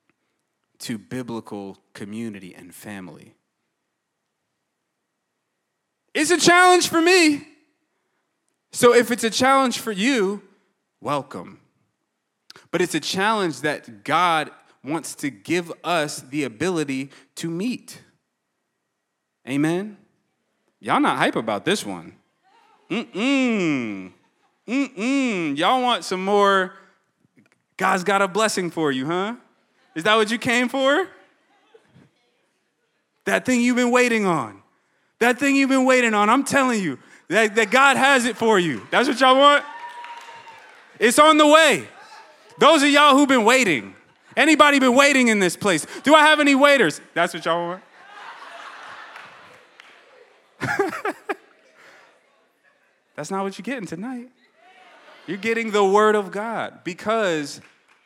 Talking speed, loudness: 130 wpm, -19 LUFS